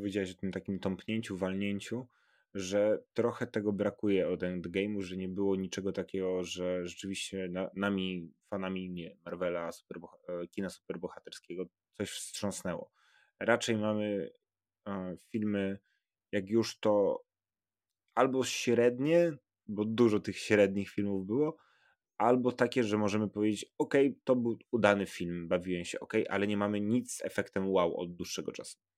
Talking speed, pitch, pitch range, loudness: 135 wpm, 100 Hz, 95-115 Hz, -33 LUFS